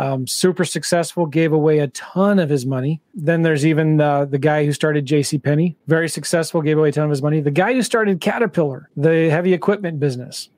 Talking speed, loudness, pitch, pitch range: 215 wpm, -18 LUFS, 160 Hz, 150-175 Hz